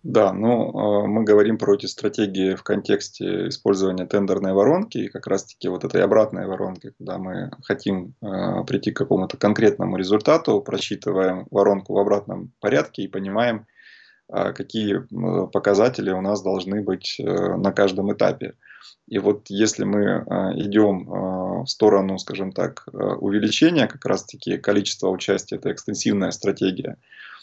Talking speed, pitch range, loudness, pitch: 135 wpm, 95-105 Hz, -22 LUFS, 100 Hz